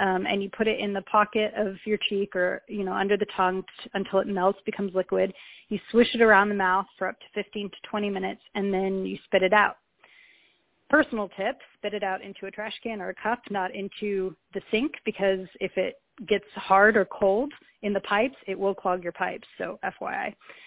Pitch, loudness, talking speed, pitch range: 195 Hz, -26 LUFS, 220 wpm, 190-210 Hz